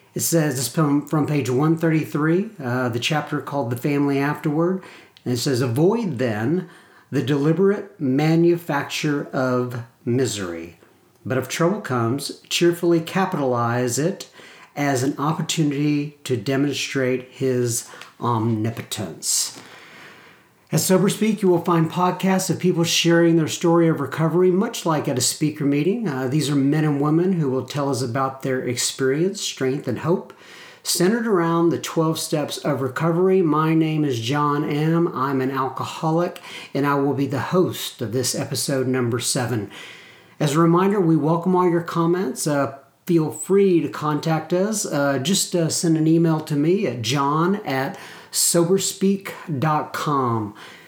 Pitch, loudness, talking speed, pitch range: 150 Hz, -21 LUFS, 145 wpm, 135-170 Hz